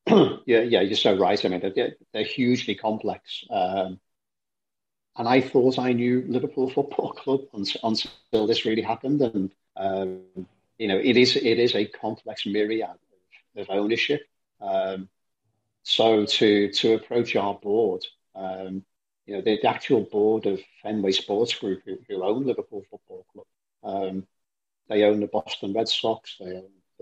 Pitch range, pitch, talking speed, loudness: 95-130 Hz, 110 Hz, 160 wpm, -24 LUFS